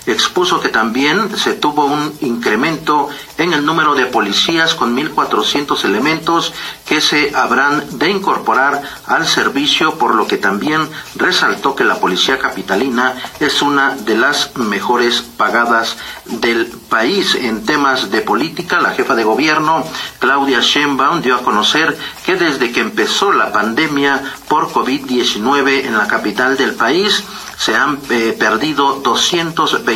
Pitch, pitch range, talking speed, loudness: 140 Hz, 120-160 Hz, 140 wpm, -13 LUFS